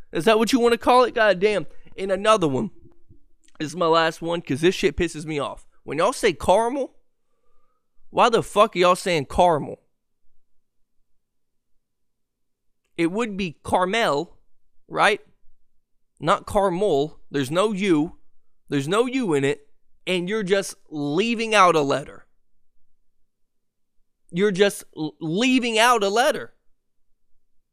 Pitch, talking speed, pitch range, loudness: 200 Hz, 140 wpm, 165-235 Hz, -21 LUFS